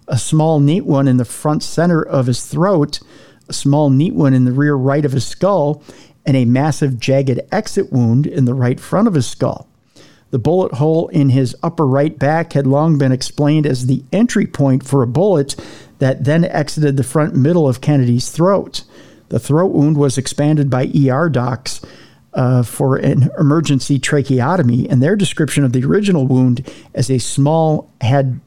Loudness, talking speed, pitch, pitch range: -15 LUFS, 185 wpm, 140 Hz, 130-155 Hz